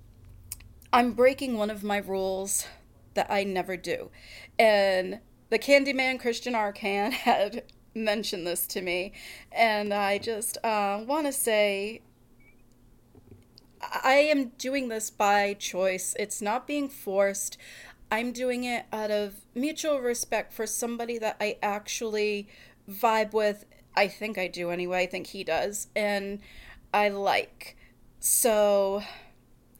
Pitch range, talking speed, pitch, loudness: 195-235 Hz, 130 wpm, 210 Hz, -27 LUFS